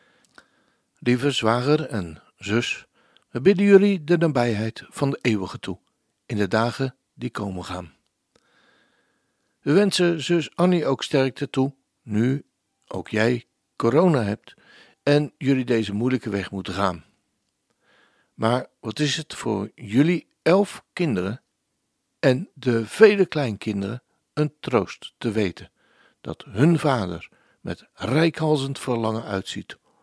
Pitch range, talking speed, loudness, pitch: 110-155 Hz, 120 wpm, -23 LUFS, 130 Hz